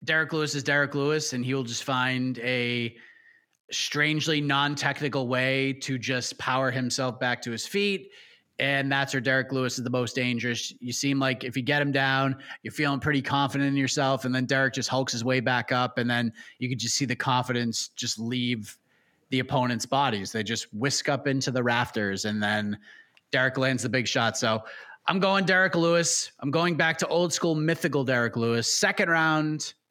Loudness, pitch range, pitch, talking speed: -26 LUFS, 125-145 Hz, 130 Hz, 195 wpm